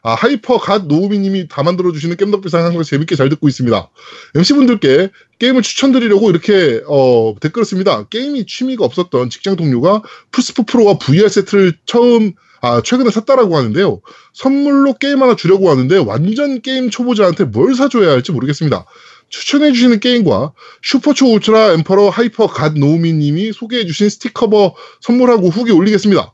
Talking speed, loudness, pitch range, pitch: 405 characters per minute, -12 LUFS, 170-245 Hz, 205 Hz